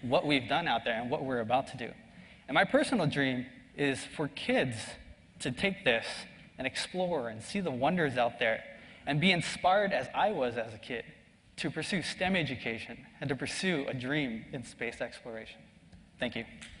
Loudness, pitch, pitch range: -32 LUFS, 150 Hz, 130-185 Hz